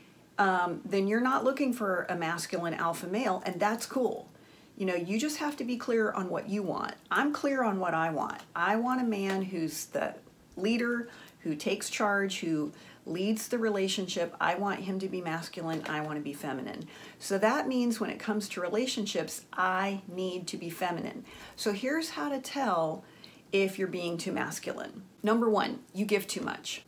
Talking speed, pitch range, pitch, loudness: 190 wpm, 175-230 Hz, 195 Hz, -31 LUFS